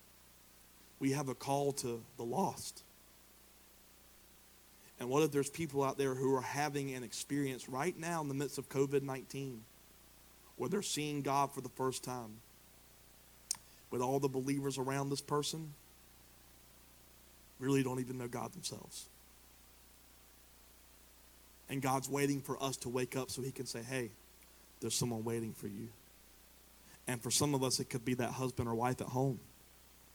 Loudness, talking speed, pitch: -38 LUFS, 160 wpm, 125 Hz